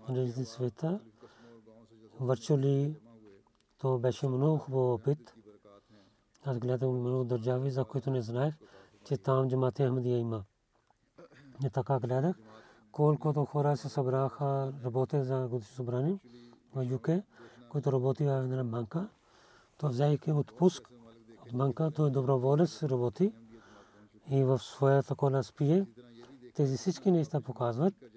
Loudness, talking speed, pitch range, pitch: -32 LUFS, 120 wpm, 120-145 Hz, 130 Hz